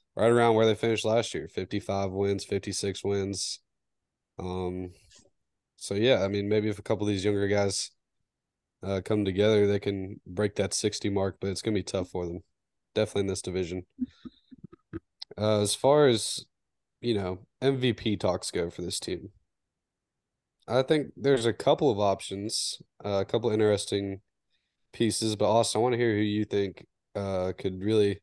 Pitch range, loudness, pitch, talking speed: 95-110 Hz, -28 LUFS, 100 Hz, 175 wpm